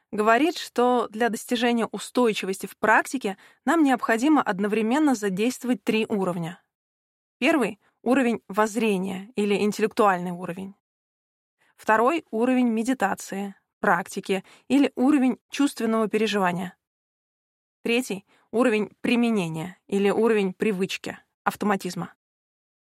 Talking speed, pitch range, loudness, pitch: 90 wpm, 195-245 Hz, -24 LUFS, 220 Hz